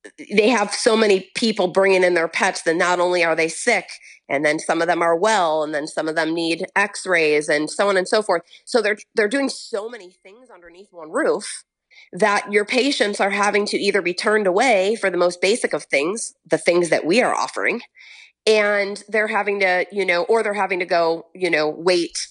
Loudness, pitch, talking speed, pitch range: -19 LUFS, 190 Hz, 220 wpm, 170-210 Hz